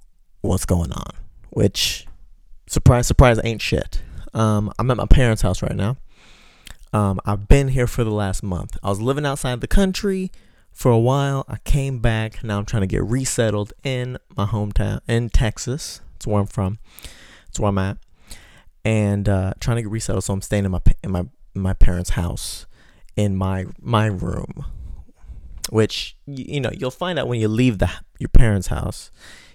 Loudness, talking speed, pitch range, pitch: -21 LUFS, 185 wpm, 95-125 Hz, 105 Hz